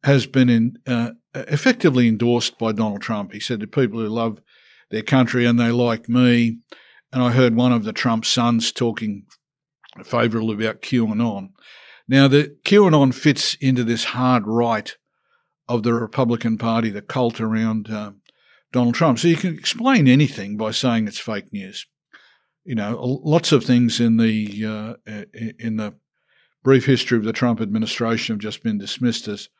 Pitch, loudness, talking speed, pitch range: 120 Hz, -19 LUFS, 165 wpm, 110-130 Hz